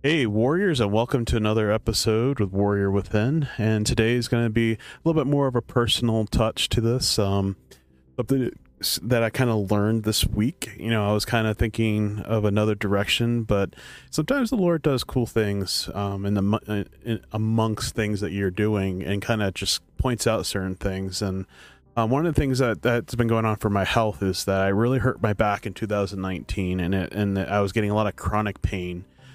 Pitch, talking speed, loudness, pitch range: 110 Hz, 210 wpm, -24 LUFS, 100-115 Hz